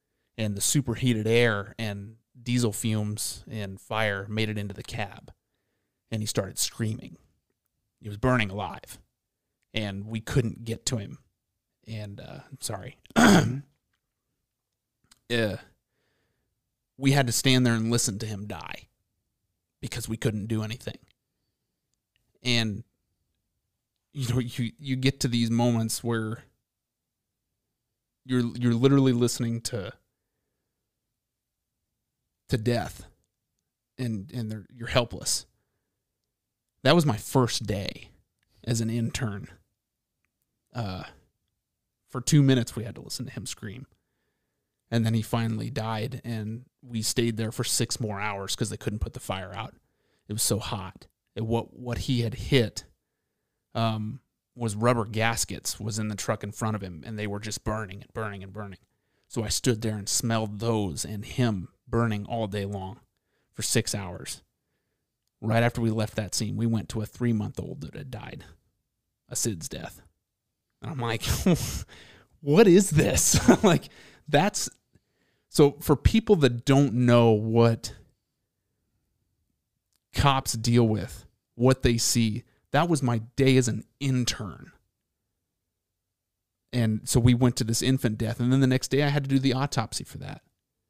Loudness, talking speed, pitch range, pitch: -26 LUFS, 145 wpm, 105-125 Hz, 115 Hz